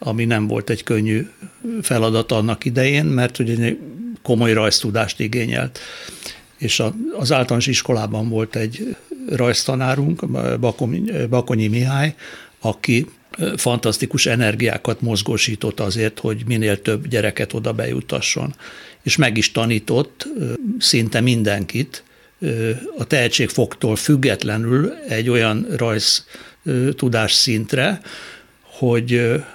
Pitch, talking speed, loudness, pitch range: 115 Hz, 100 wpm, -19 LUFS, 110-130 Hz